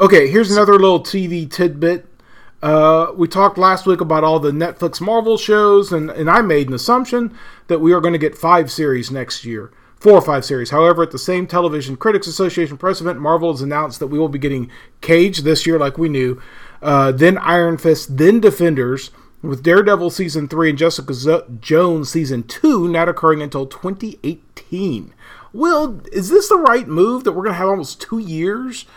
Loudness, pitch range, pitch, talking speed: -15 LUFS, 150-190 Hz, 170 Hz, 195 wpm